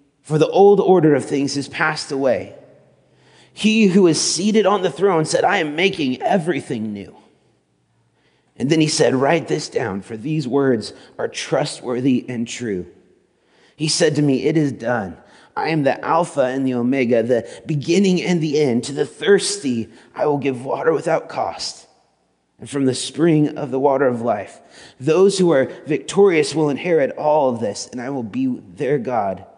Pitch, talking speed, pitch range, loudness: 150 Hz, 180 wpm, 130-170 Hz, -18 LUFS